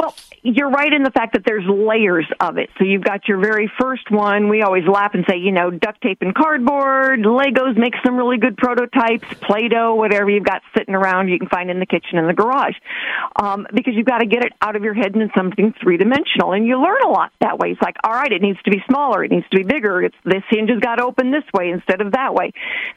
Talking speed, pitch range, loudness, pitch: 260 wpm, 195-255 Hz, -17 LUFS, 220 Hz